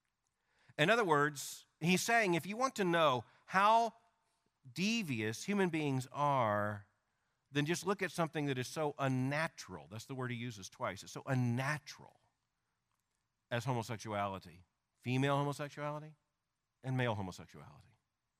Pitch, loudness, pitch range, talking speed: 135 Hz, -36 LUFS, 120-155 Hz, 130 wpm